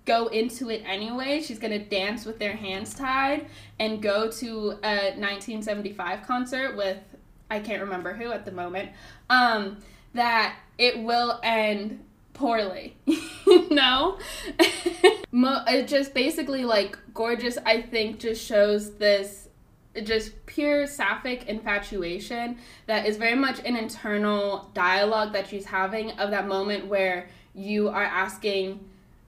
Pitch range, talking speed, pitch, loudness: 200-245 Hz, 130 wpm, 220 Hz, -25 LUFS